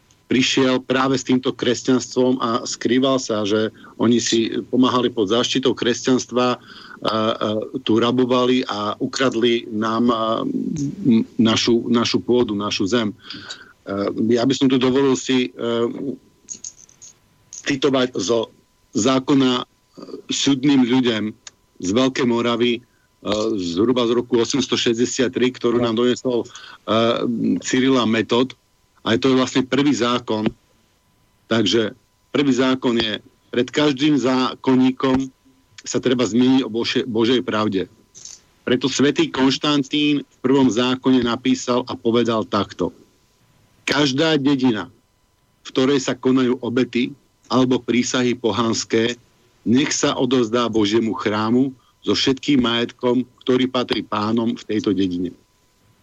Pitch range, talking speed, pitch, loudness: 115-130 Hz, 115 wpm, 125 Hz, -19 LUFS